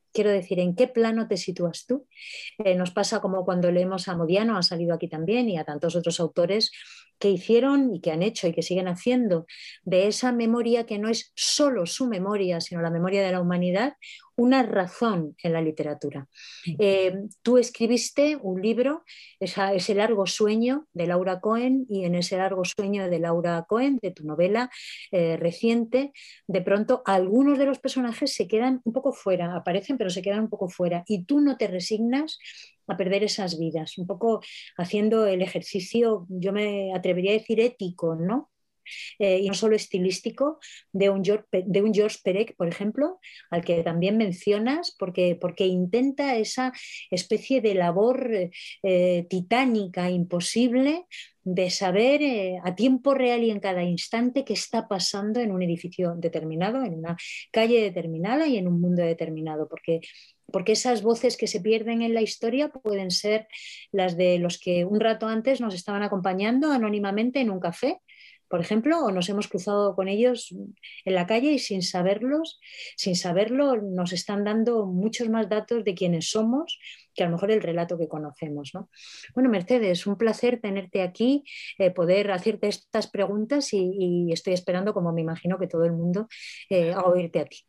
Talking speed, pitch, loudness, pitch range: 175 wpm, 200 Hz, -25 LUFS, 180-230 Hz